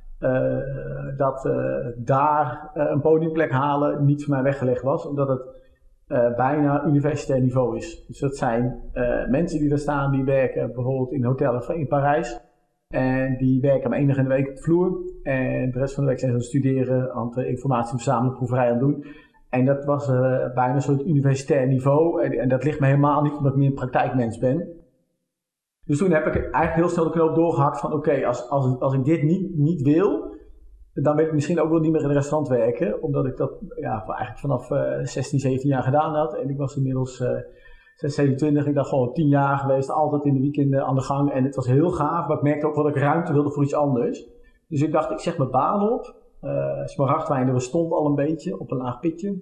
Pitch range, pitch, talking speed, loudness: 130-150 Hz, 140 Hz, 225 wpm, -22 LUFS